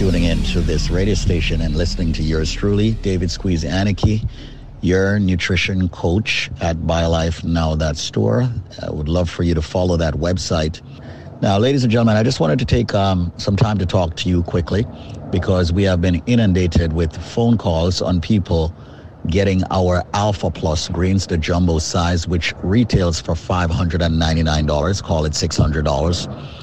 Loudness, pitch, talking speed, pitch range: -18 LUFS, 90 Hz, 165 wpm, 85-100 Hz